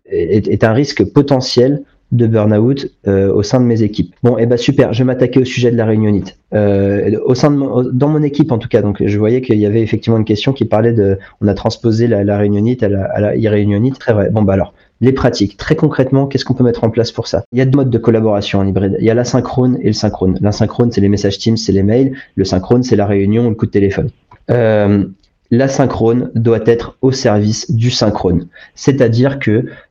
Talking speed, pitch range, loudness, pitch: 240 wpm, 105-125 Hz, -13 LUFS, 115 Hz